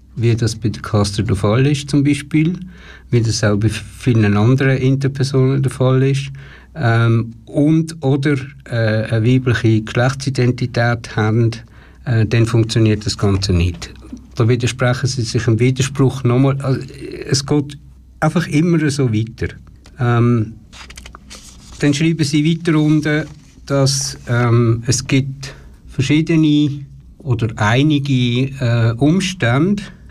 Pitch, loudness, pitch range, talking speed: 125 Hz, -16 LUFS, 115-140 Hz, 125 wpm